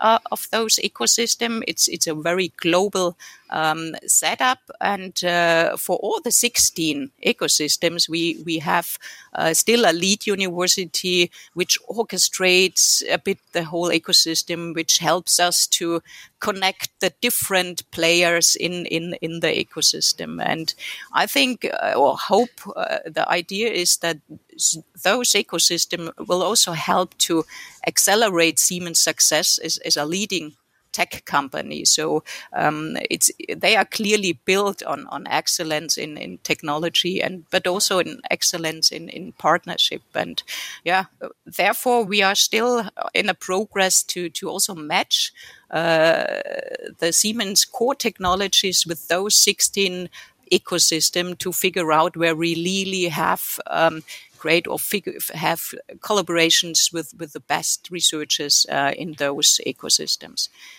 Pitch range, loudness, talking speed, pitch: 165-200 Hz, -19 LUFS, 135 wpm, 175 Hz